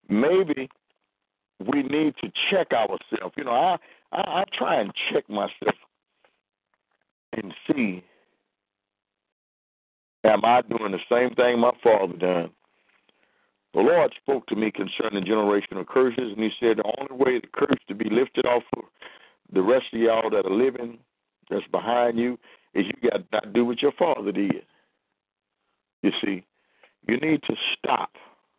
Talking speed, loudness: 155 wpm, -24 LUFS